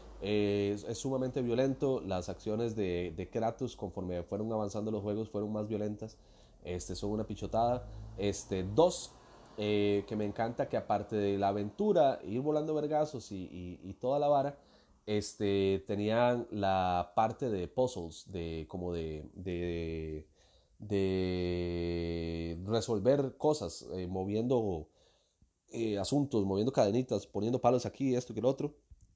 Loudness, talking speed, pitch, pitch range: -34 LUFS, 140 wpm, 105 Hz, 90-115 Hz